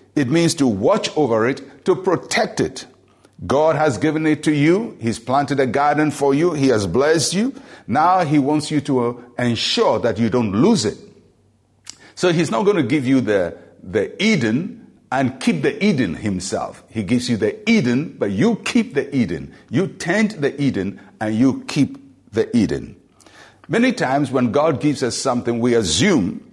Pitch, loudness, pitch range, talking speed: 140 Hz, -19 LUFS, 125-165 Hz, 180 wpm